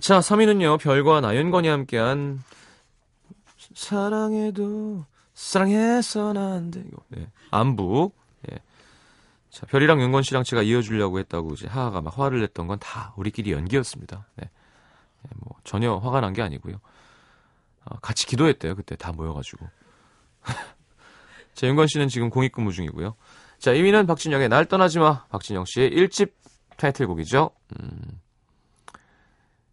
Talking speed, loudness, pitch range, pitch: 270 characters per minute, -22 LUFS, 105-170 Hz, 135 Hz